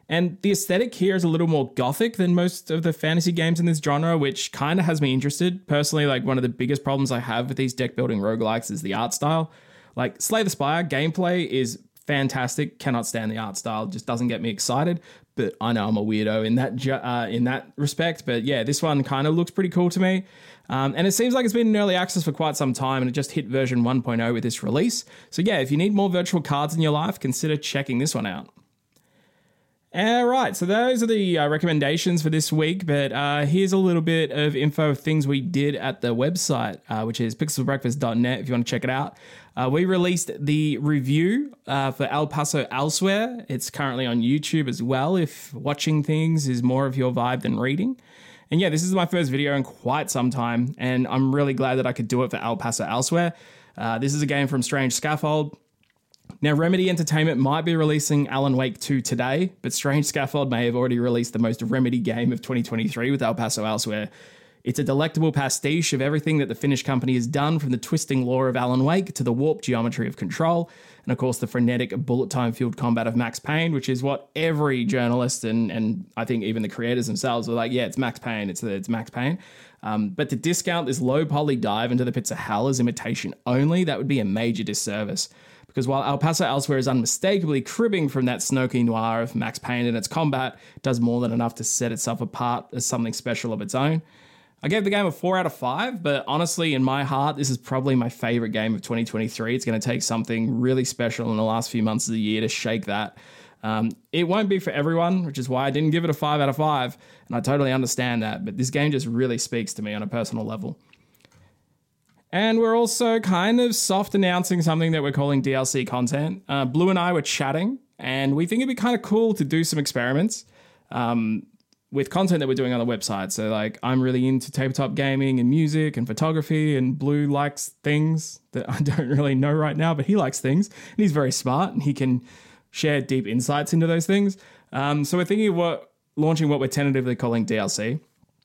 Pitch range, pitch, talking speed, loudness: 125-160 Hz, 140 Hz, 230 wpm, -23 LUFS